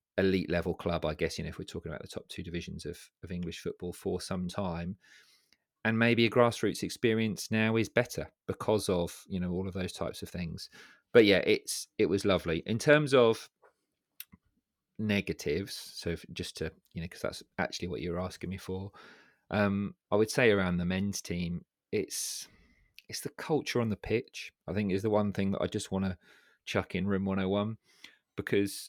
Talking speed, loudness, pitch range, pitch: 195 wpm, -31 LUFS, 90-105 Hz, 95 Hz